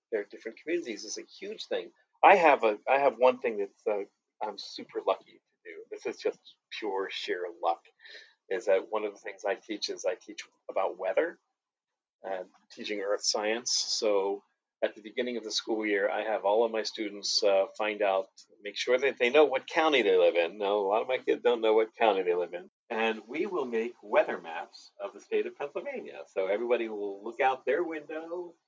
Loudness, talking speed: -29 LUFS, 215 wpm